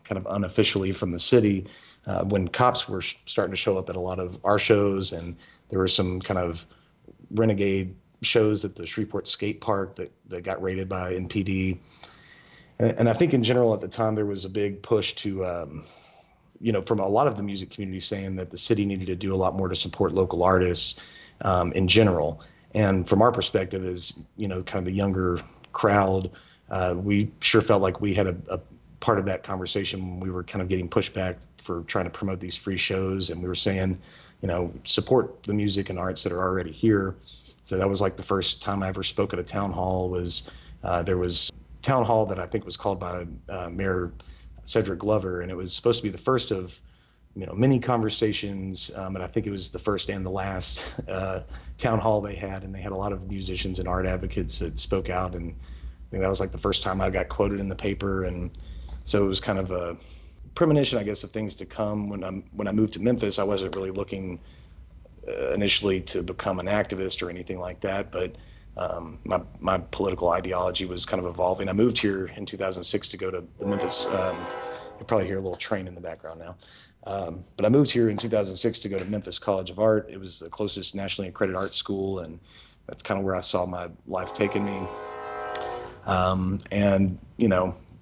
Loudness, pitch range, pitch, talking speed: -26 LUFS, 90-100 Hz, 95 Hz, 220 wpm